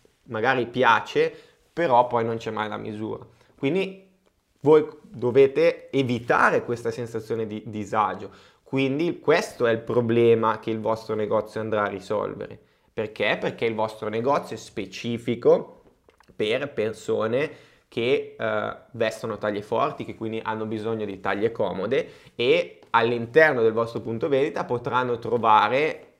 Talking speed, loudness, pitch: 135 wpm, -24 LUFS, 120 Hz